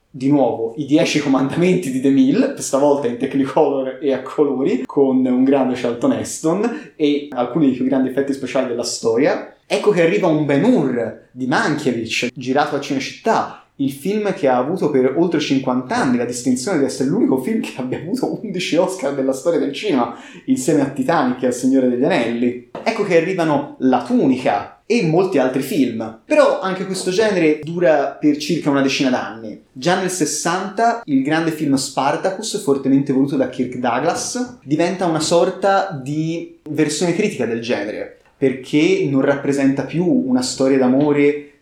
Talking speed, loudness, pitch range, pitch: 170 wpm, -18 LUFS, 130-175 Hz, 145 Hz